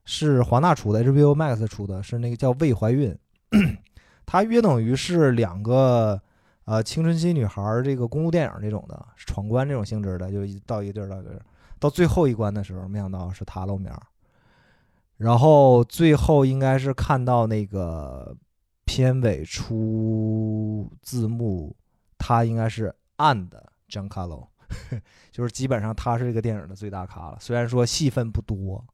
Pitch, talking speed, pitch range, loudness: 110 Hz, 260 characters per minute, 100-130 Hz, -23 LUFS